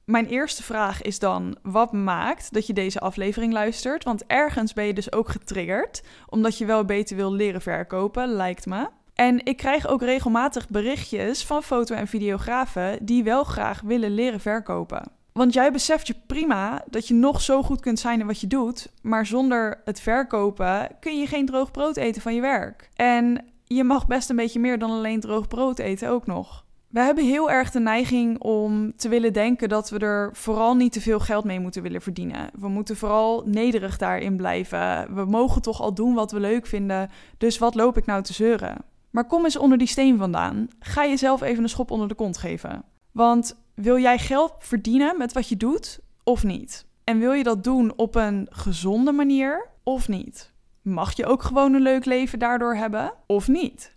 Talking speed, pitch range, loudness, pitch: 200 wpm, 210-255 Hz, -23 LUFS, 230 Hz